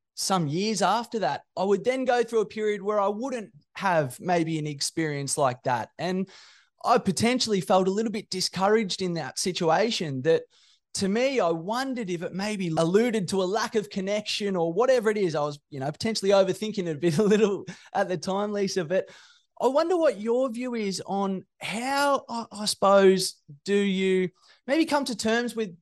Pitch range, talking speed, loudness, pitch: 180-225 Hz, 190 wpm, -26 LUFS, 200 Hz